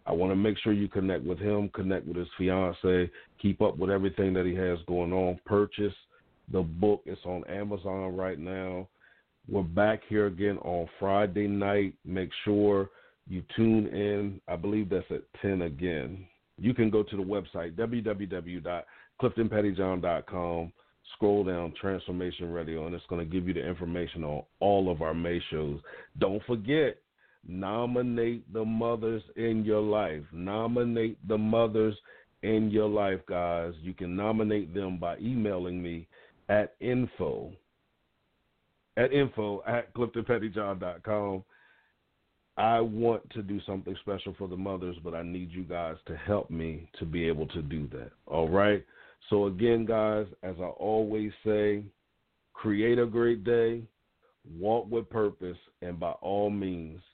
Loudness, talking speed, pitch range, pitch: -30 LUFS, 150 wpm, 90-110 Hz, 100 Hz